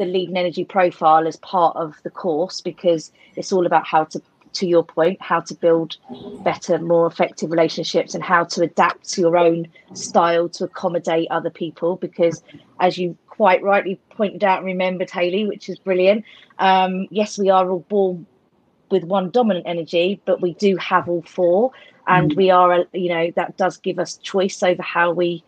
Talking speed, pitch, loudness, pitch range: 185 wpm, 180 Hz, -19 LUFS, 170-190 Hz